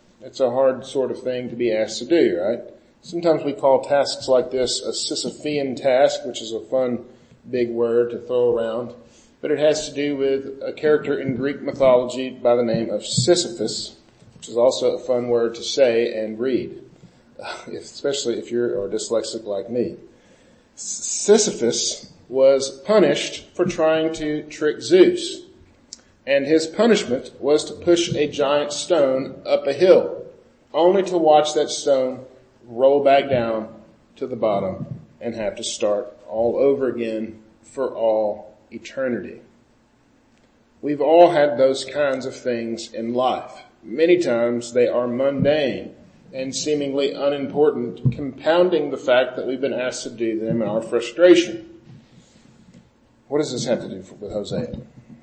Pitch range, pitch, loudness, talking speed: 120-160 Hz, 135 Hz, -20 LUFS, 155 wpm